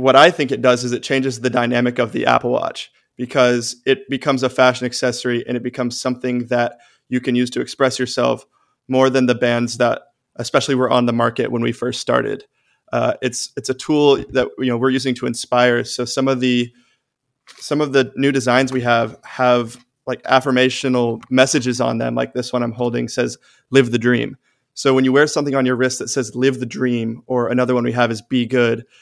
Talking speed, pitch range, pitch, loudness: 215 wpm, 120-130 Hz, 125 Hz, -18 LUFS